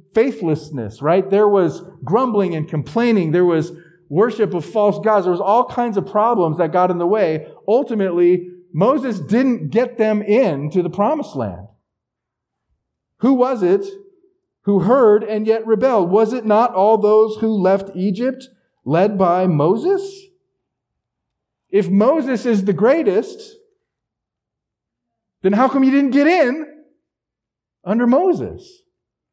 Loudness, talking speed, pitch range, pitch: -17 LUFS, 135 wpm, 180-260 Hz, 210 Hz